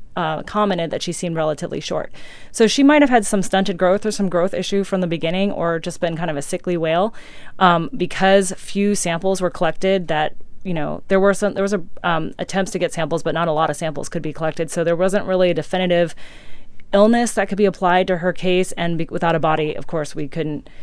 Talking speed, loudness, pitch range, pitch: 235 wpm, -19 LUFS, 165-195 Hz, 180 Hz